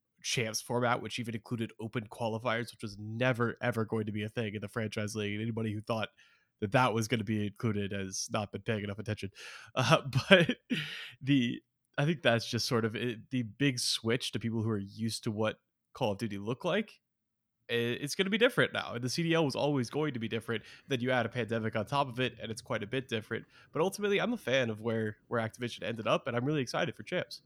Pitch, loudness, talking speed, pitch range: 115 Hz, -33 LUFS, 240 wpm, 110-125 Hz